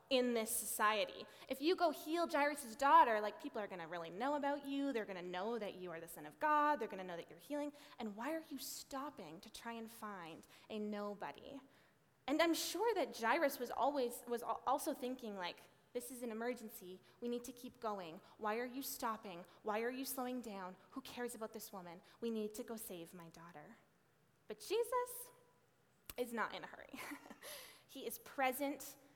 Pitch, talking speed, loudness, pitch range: 235 Hz, 200 wpm, -41 LUFS, 205-275 Hz